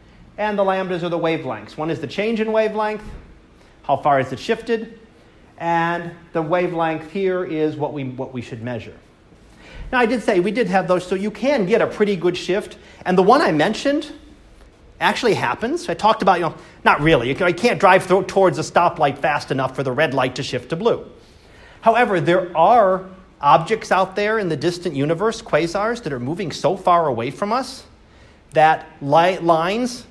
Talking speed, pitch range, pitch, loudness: 195 wpm, 160-210 Hz, 180 Hz, -19 LUFS